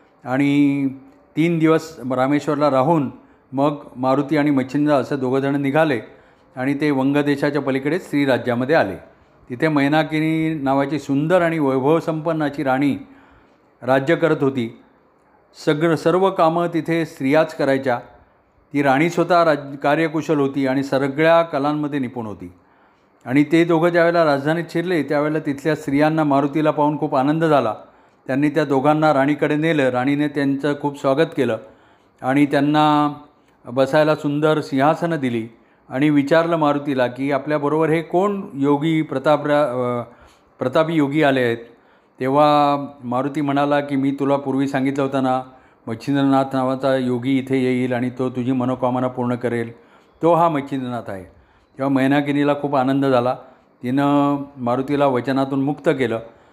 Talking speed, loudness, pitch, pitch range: 135 wpm, -19 LUFS, 140 Hz, 130-155 Hz